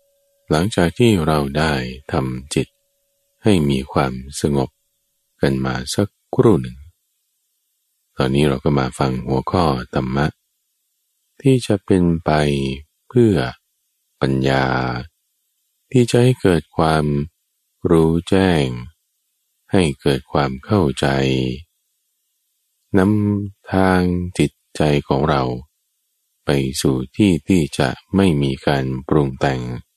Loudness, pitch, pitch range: -18 LUFS, 75 Hz, 65-95 Hz